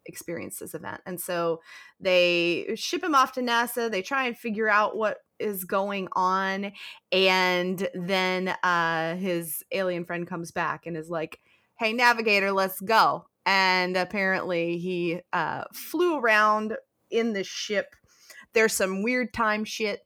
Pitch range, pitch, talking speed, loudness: 180-220 Hz, 190 Hz, 145 wpm, -25 LUFS